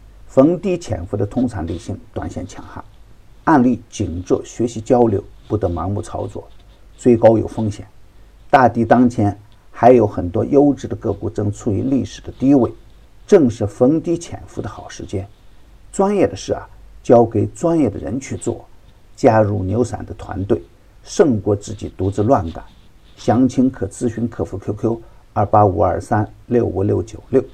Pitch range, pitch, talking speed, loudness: 100-120 Hz, 105 Hz, 240 characters per minute, -17 LUFS